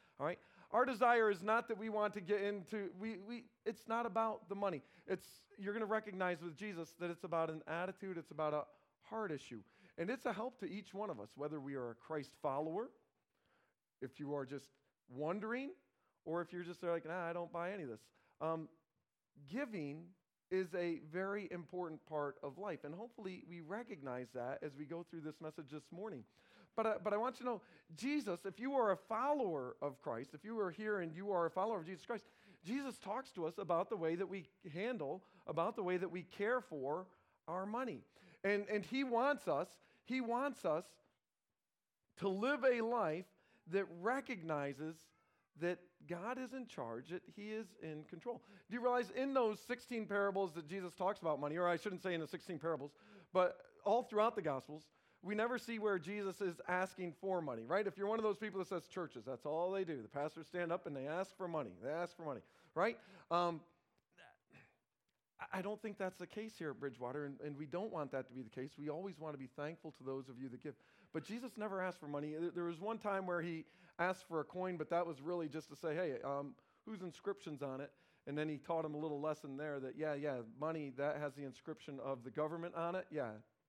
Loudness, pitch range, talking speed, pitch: -43 LUFS, 155-210 Hz, 220 wpm, 175 Hz